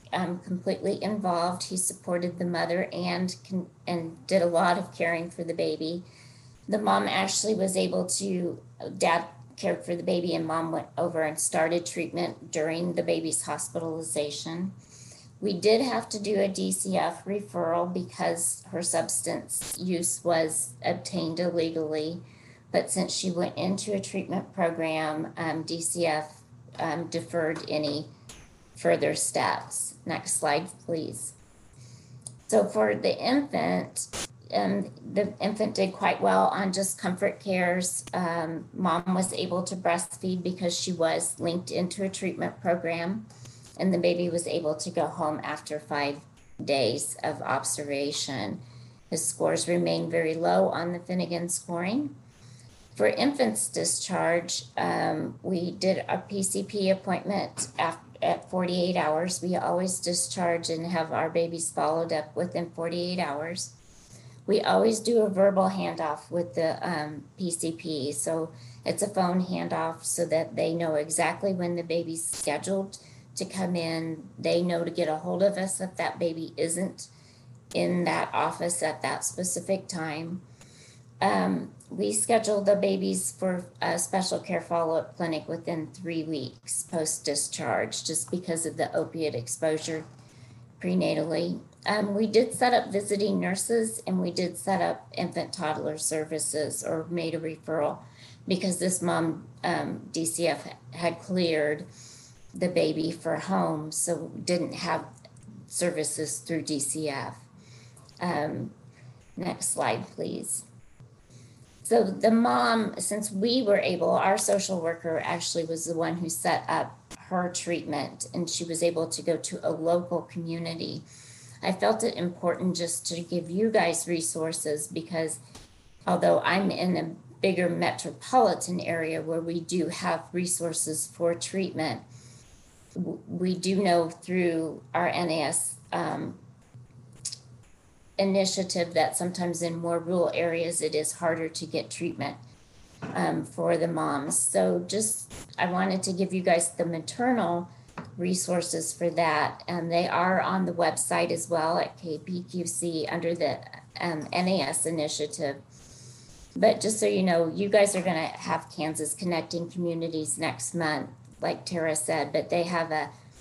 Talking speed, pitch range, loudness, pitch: 140 wpm, 150-180 Hz, -28 LUFS, 165 Hz